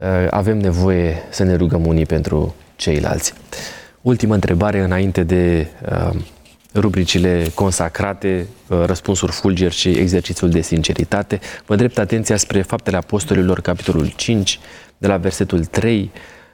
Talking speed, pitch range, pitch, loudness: 125 wpm, 85-100 Hz, 95 Hz, -17 LUFS